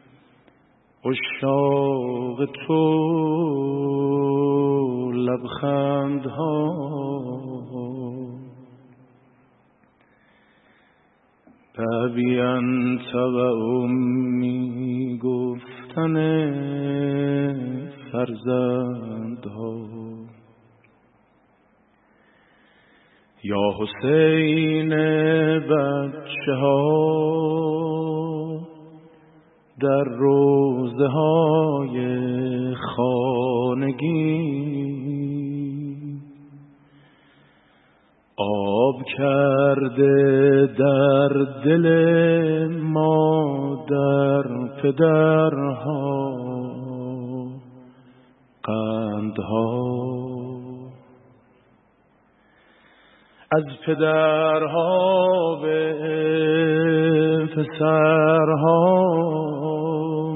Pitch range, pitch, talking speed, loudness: 125-155 Hz, 140 Hz, 30 wpm, -21 LUFS